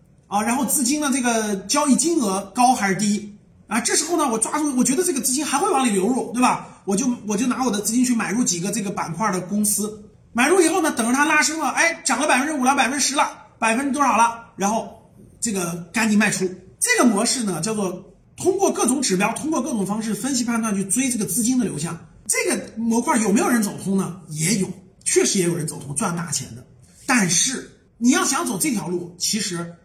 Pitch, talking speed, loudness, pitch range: 225 Hz, 330 characters per minute, -20 LUFS, 195-270 Hz